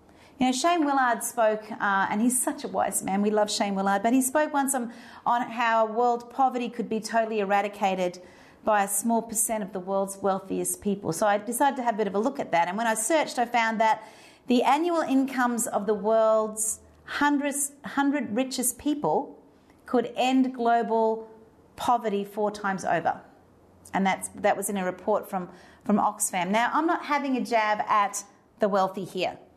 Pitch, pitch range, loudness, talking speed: 225 Hz, 205-250 Hz, -26 LUFS, 190 wpm